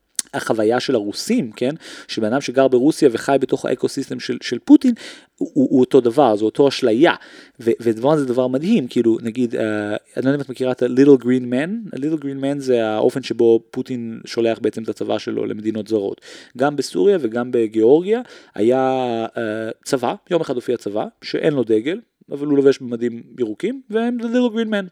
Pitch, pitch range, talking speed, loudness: 130 Hz, 115-165 Hz, 180 wpm, -19 LUFS